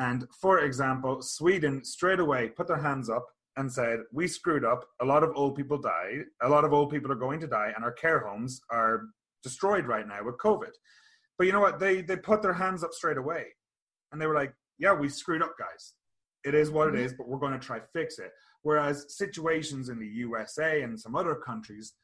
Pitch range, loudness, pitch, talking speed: 125-175 Hz, -29 LUFS, 145 Hz, 225 wpm